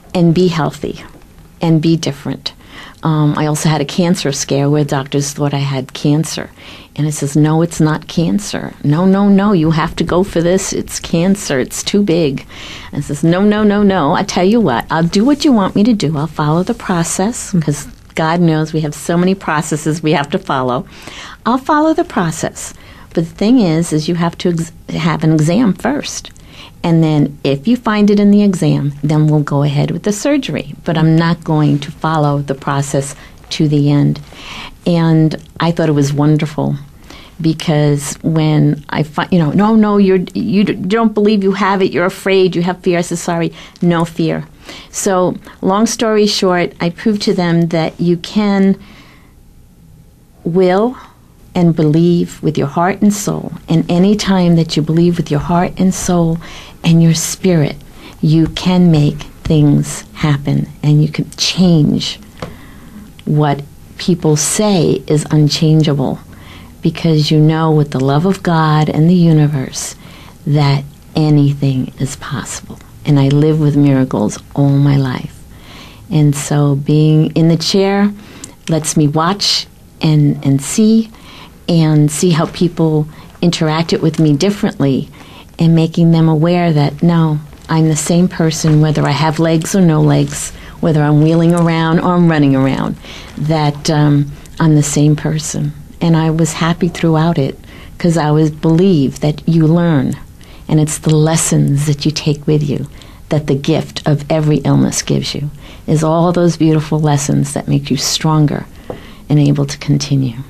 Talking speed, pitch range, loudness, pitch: 170 wpm, 145-175 Hz, -13 LUFS, 160 Hz